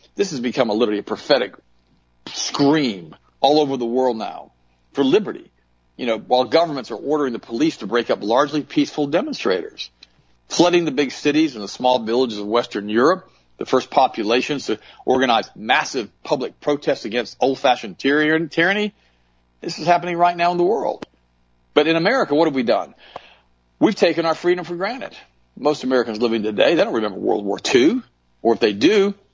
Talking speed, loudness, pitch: 175 wpm, -19 LUFS, 140 Hz